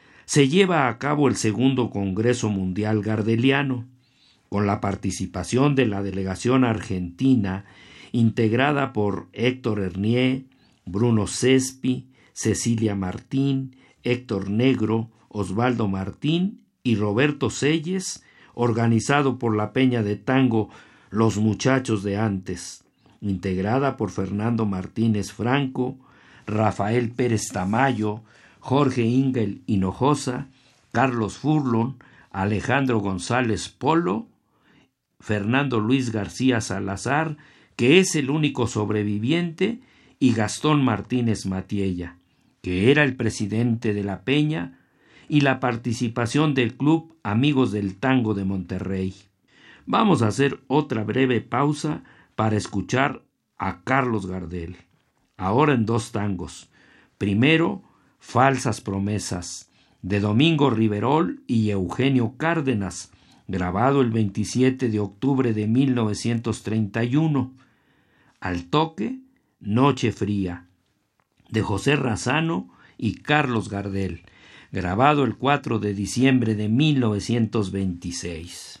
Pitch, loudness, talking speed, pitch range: 115 Hz, -23 LUFS, 105 wpm, 100-130 Hz